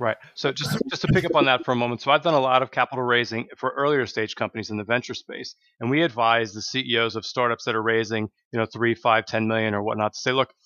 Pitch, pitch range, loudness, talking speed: 120 Hz, 110-130 Hz, -23 LUFS, 275 wpm